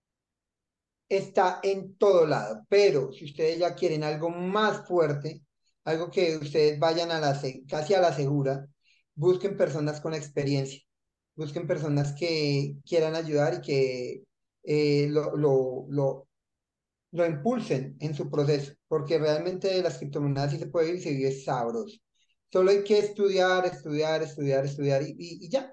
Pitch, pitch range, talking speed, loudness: 155 Hz, 140-180 Hz, 145 wpm, -27 LUFS